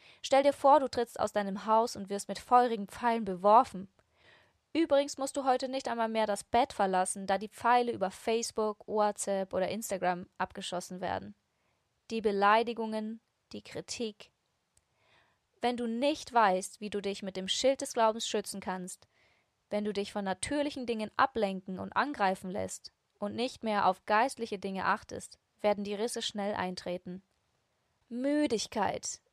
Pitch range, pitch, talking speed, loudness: 195-235 Hz, 210 Hz, 155 wpm, -31 LUFS